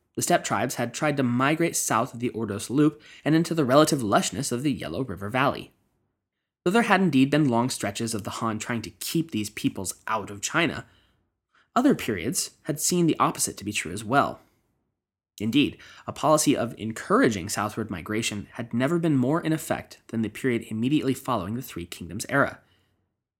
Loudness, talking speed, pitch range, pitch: -25 LUFS, 185 wpm, 105-150 Hz, 120 Hz